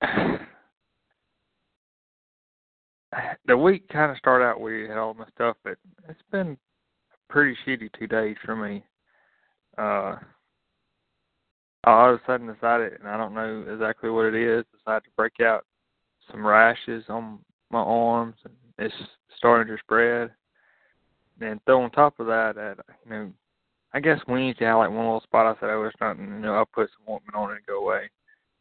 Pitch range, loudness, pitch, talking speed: 110-130 Hz, -24 LUFS, 115 Hz, 180 wpm